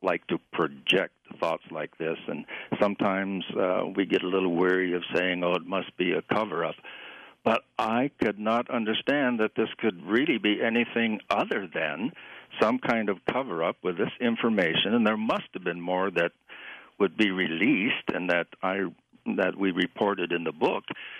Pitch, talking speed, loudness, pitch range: 95 Hz, 180 wpm, -27 LUFS, 90-110 Hz